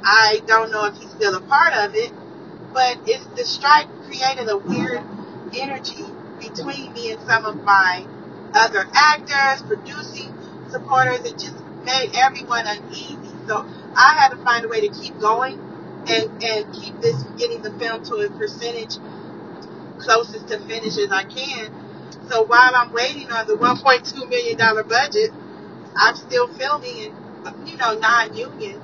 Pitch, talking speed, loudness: 250 Hz, 155 wpm, -18 LUFS